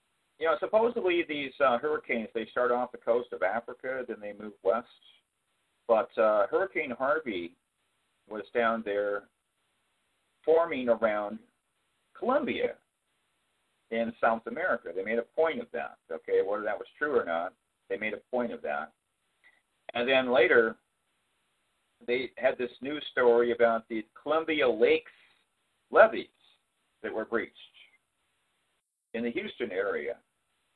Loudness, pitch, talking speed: -29 LUFS, 125 Hz, 135 wpm